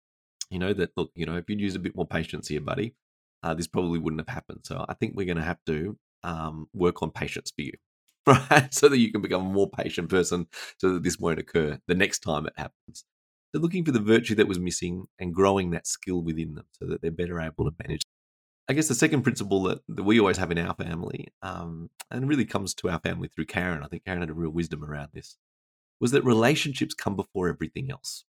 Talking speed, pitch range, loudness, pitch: 240 wpm, 80-105 Hz, -27 LUFS, 90 Hz